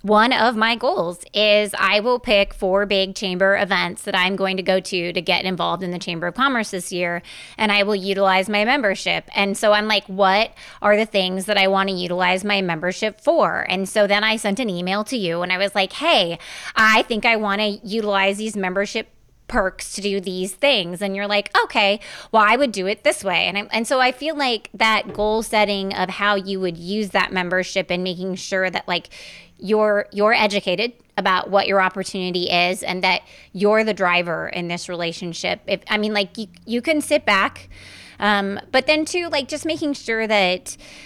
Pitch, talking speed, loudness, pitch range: 200 Hz, 210 wpm, -19 LUFS, 185-215 Hz